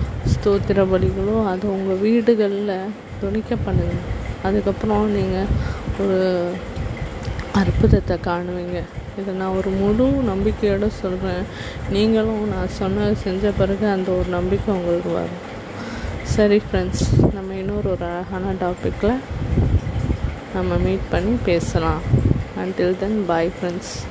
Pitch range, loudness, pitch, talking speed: 180-205 Hz, -21 LUFS, 195 Hz, 105 wpm